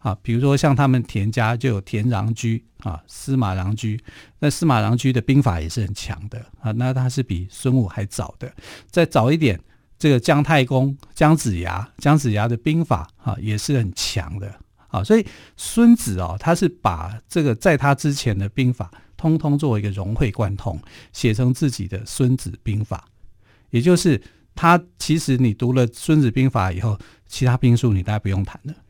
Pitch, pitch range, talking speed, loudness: 120 Hz, 105-140 Hz, 270 characters per minute, -20 LUFS